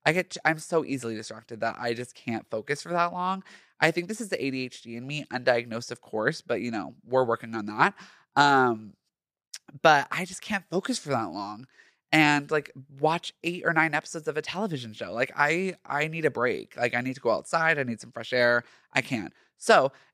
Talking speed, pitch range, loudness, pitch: 215 wpm, 120-165 Hz, -27 LUFS, 145 Hz